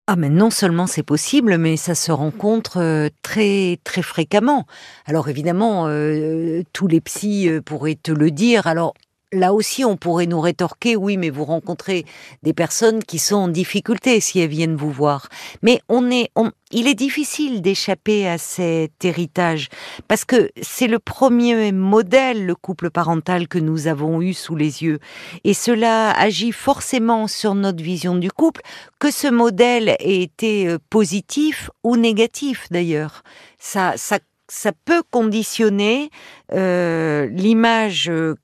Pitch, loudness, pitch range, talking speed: 190 Hz, -18 LUFS, 165-225 Hz, 155 wpm